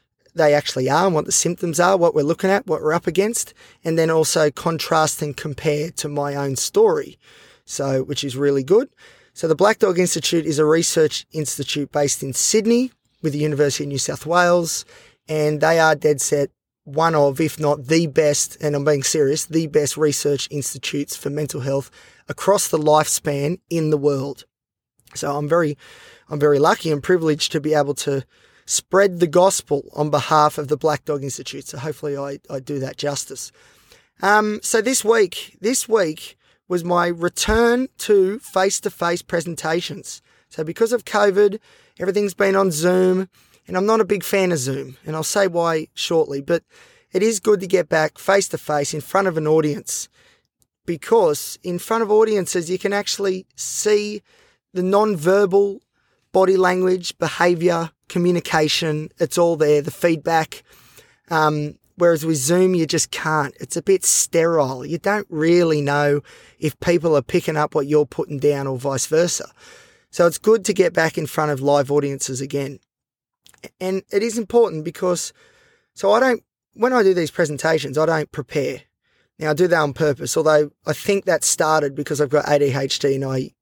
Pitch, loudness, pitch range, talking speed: 160 Hz, -19 LUFS, 150-190 Hz, 180 wpm